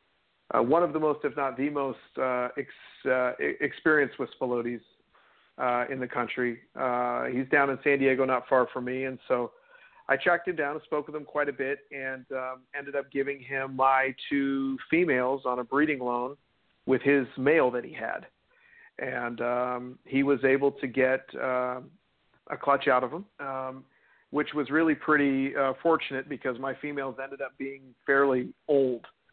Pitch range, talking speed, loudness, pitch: 130-145 Hz, 180 wpm, -28 LUFS, 135 Hz